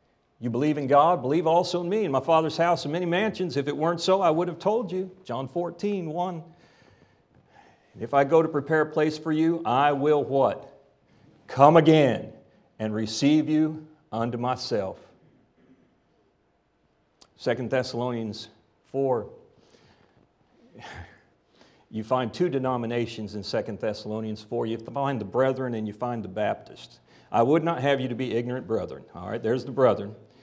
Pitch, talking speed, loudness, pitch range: 140 Hz, 160 wpm, -25 LUFS, 120-165 Hz